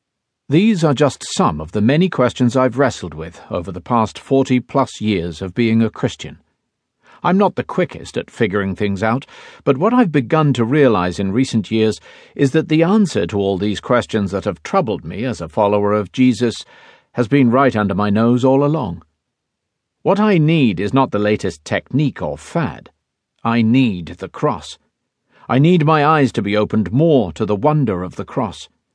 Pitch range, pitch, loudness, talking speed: 100-140 Hz, 115 Hz, -17 LUFS, 190 wpm